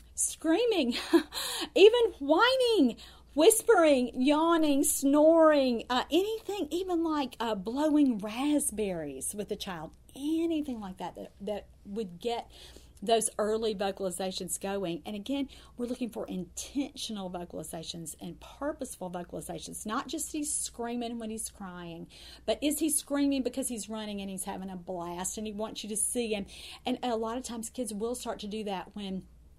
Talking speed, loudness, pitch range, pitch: 150 wpm, -30 LUFS, 200-295 Hz, 235 Hz